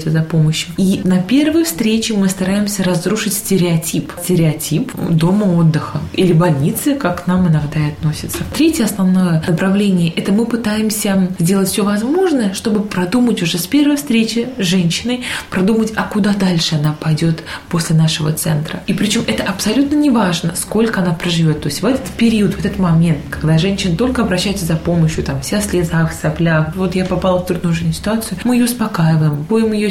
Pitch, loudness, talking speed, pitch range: 185 Hz, -15 LUFS, 170 wpm, 165-215 Hz